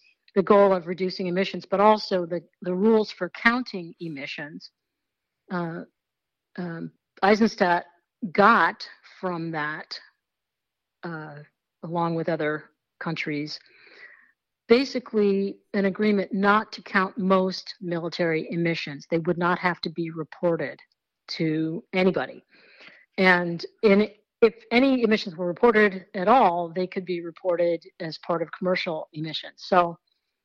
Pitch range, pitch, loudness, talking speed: 170-205 Hz, 180 Hz, -24 LUFS, 120 wpm